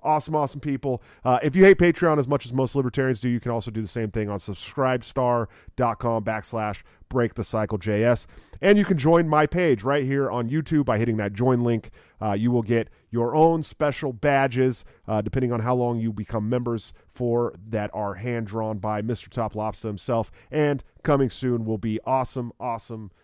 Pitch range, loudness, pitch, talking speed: 110-135 Hz, -24 LUFS, 120 Hz, 185 wpm